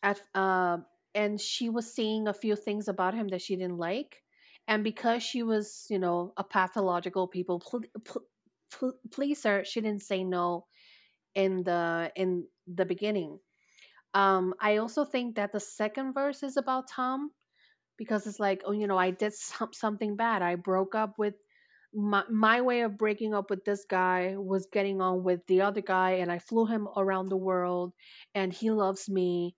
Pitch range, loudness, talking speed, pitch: 185-220 Hz, -30 LUFS, 185 wpm, 200 Hz